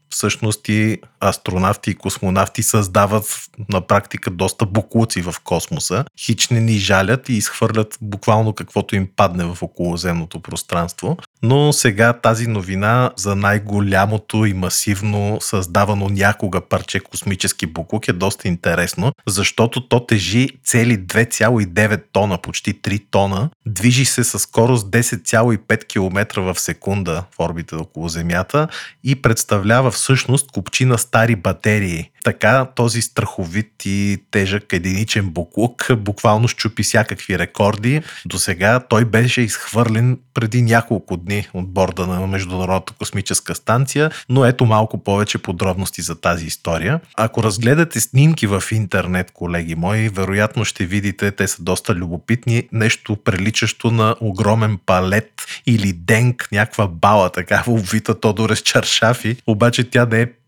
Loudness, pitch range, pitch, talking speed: -17 LUFS, 95-115 Hz, 105 Hz, 130 wpm